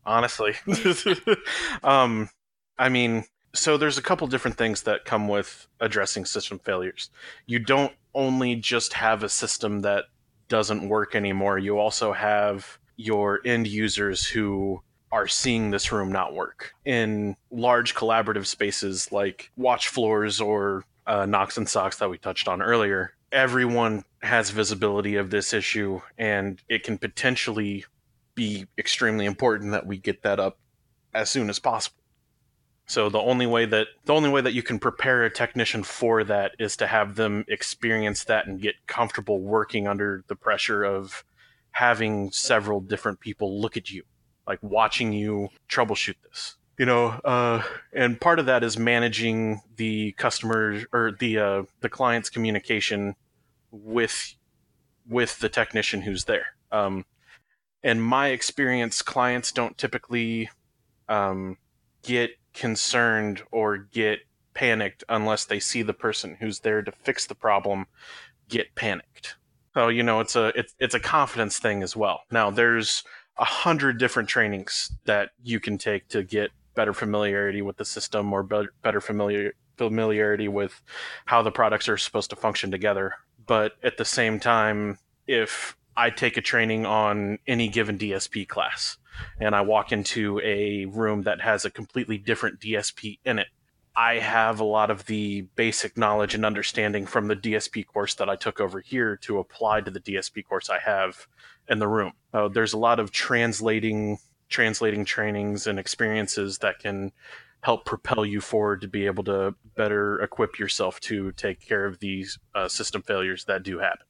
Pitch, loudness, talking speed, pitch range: 110 Hz, -25 LUFS, 160 wpm, 100-115 Hz